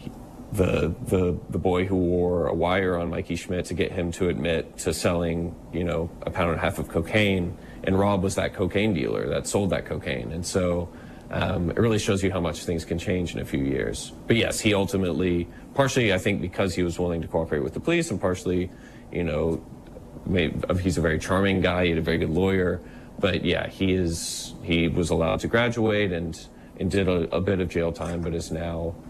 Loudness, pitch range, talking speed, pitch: -25 LUFS, 85-95 Hz, 220 wpm, 90 Hz